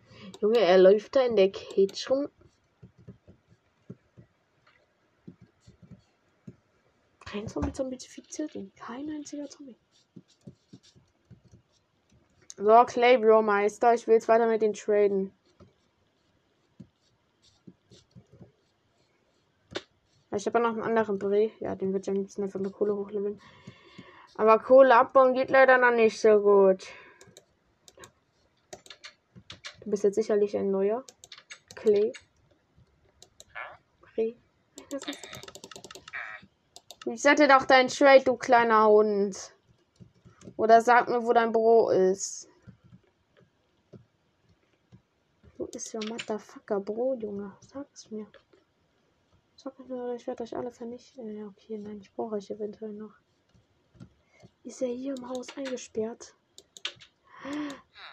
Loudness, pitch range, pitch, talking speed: -25 LUFS, 210-255 Hz, 225 Hz, 105 wpm